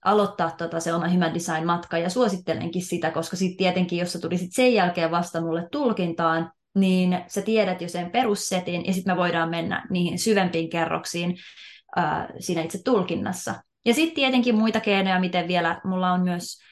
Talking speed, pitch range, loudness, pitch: 170 wpm, 170-195 Hz, -24 LUFS, 180 Hz